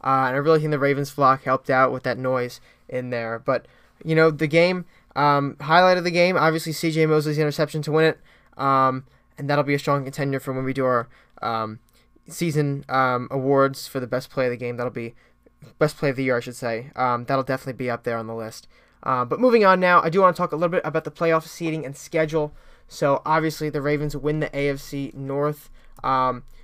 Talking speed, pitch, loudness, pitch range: 230 wpm, 140 Hz, -22 LUFS, 130-160 Hz